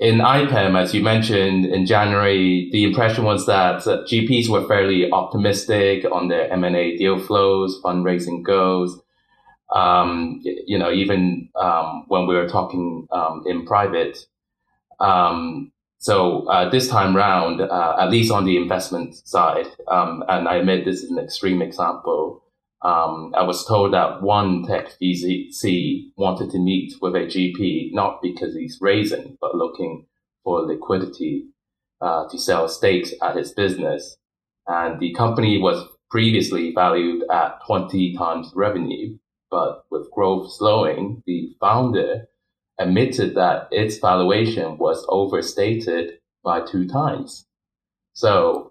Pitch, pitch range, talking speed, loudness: 95 Hz, 90-105 Hz, 135 wpm, -20 LUFS